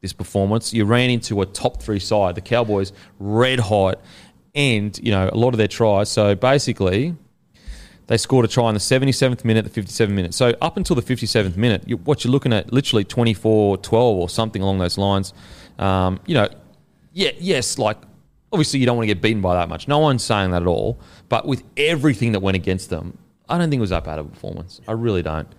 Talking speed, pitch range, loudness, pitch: 225 wpm, 95-120 Hz, -19 LUFS, 110 Hz